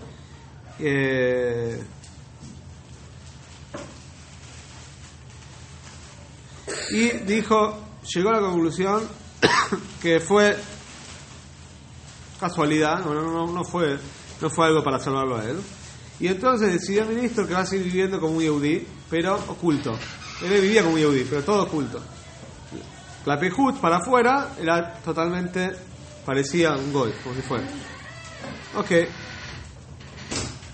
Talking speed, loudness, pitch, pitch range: 110 wpm, -23 LUFS, 165 Hz, 140-190 Hz